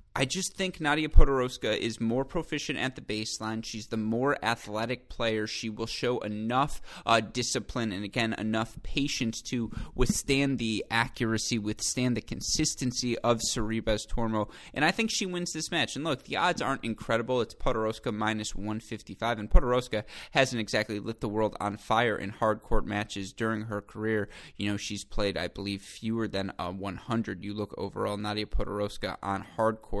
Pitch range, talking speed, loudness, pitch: 105-125 Hz, 175 wpm, -30 LUFS, 110 Hz